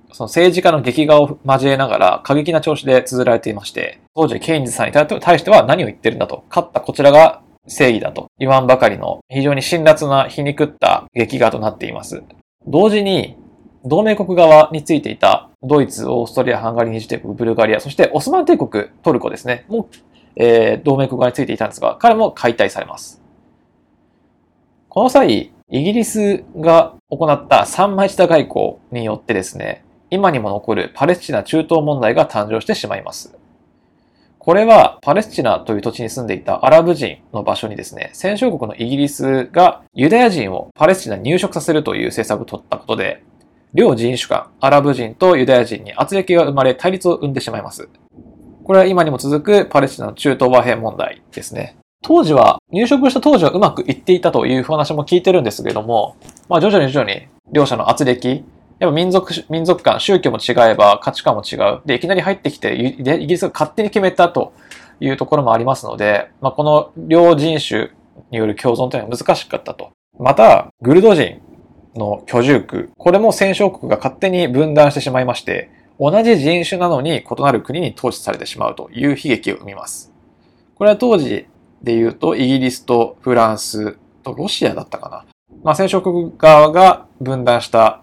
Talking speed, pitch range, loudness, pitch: 375 characters per minute, 125-180 Hz, -14 LUFS, 150 Hz